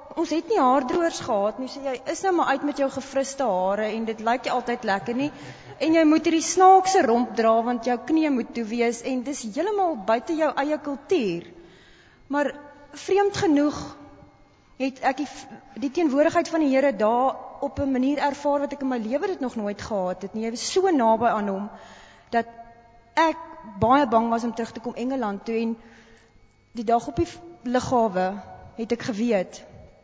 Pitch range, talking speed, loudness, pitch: 230-295 Hz, 190 wpm, -24 LUFS, 260 Hz